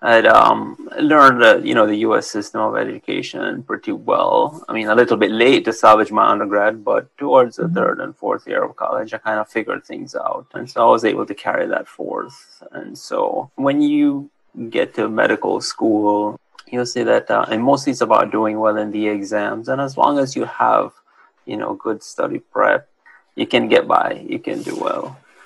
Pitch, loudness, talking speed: 140 Hz, -17 LUFS, 205 wpm